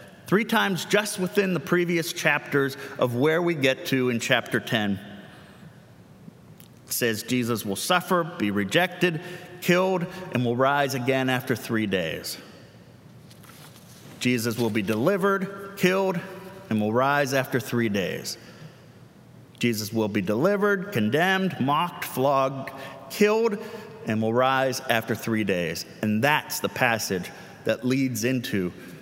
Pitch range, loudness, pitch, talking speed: 120-180 Hz, -25 LUFS, 135 Hz, 130 wpm